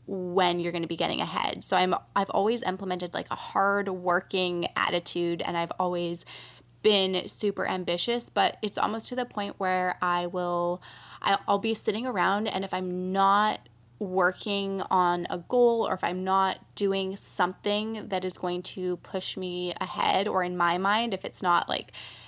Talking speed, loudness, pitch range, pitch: 175 wpm, -28 LUFS, 180-200 Hz, 185 Hz